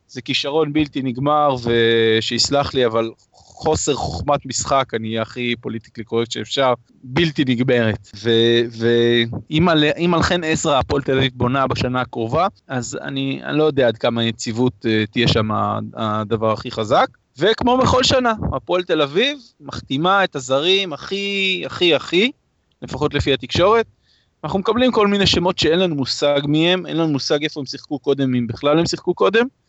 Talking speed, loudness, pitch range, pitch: 160 wpm, -18 LUFS, 115-160 Hz, 135 Hz